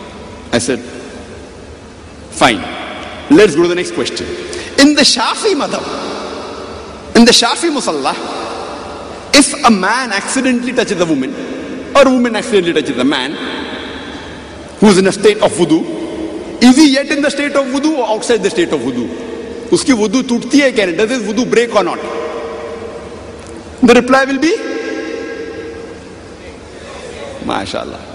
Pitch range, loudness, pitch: 210-285 Hz, -12 LUFS, 245 Hz